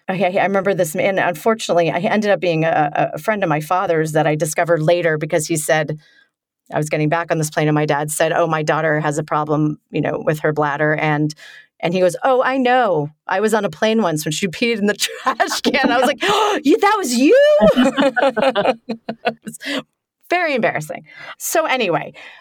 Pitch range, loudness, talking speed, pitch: 160-245 Hz, -17 LUFS, 205 wpm, 185 Hz